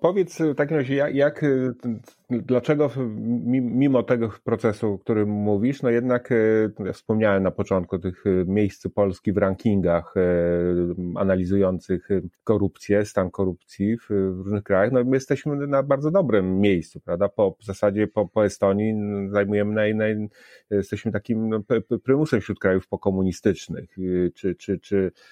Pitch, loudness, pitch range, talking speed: 105 Hz, -23 LUFS, 95-120 Hz, 145 wpm